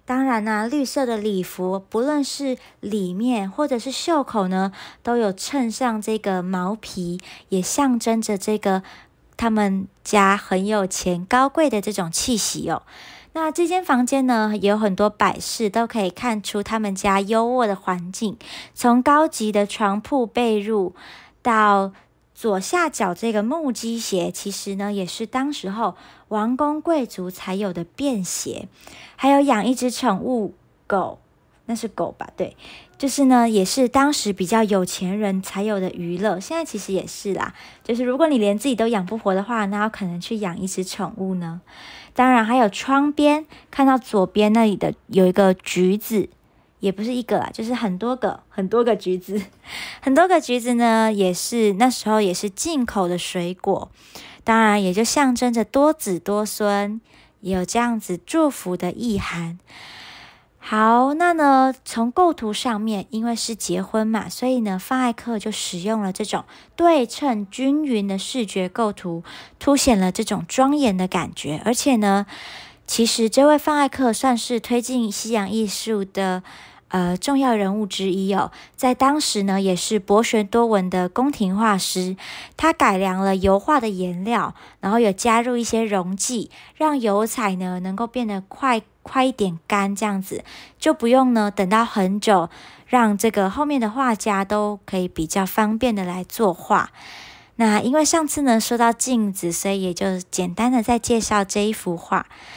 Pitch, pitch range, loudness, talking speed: 215 Hz, 195-245 Hz, -21 LUFS, 240 characters per minute